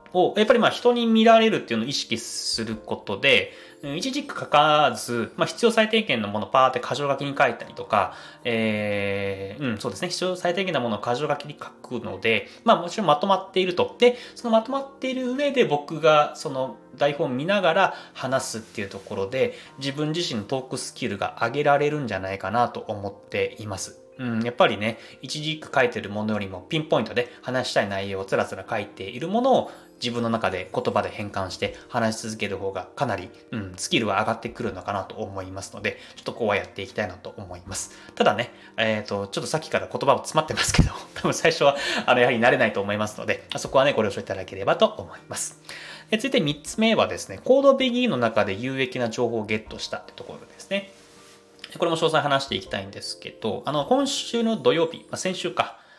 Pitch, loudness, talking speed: 135 Hz, -24 LUFS, 435 characters per minute